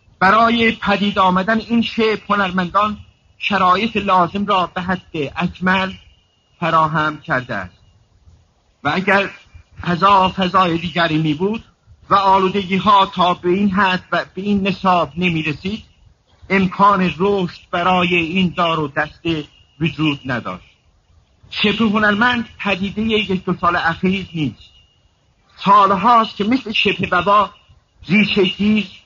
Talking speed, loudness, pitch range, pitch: 120 wpm, -16 LUFS, 160-200 Hz, 185 Hz